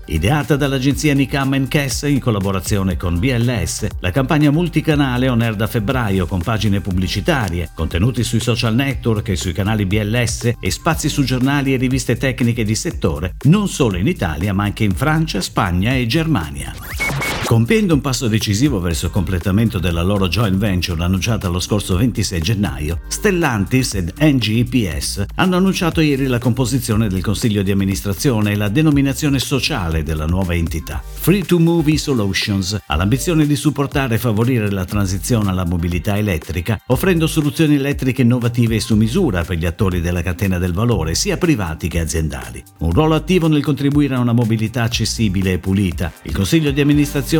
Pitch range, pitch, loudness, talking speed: 95-140 Hz, 115 Hz, -17 LUFS, 165 wpm